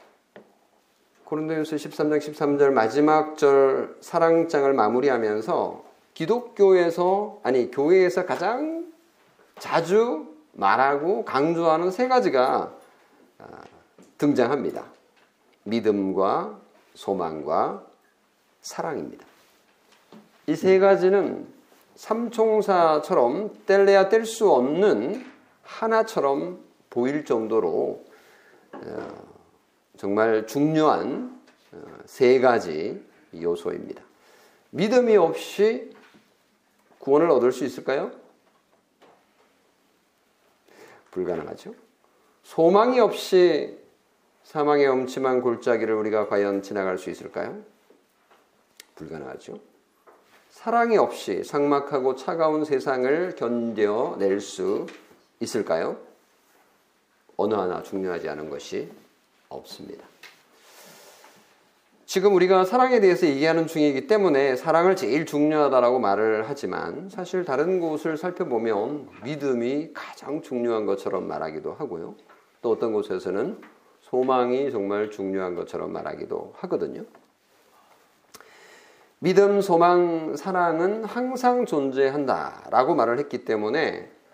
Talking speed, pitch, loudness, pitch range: 215 characters per minute, 160 Hz, -23 LUFS, 135-210 Hz